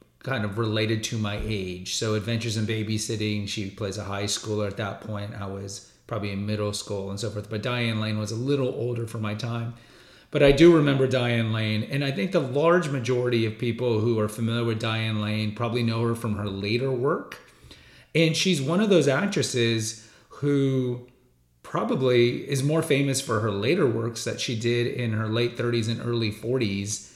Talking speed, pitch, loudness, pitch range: 195 wpm, 115 Hz, -25 LUFS, 105-125 Hz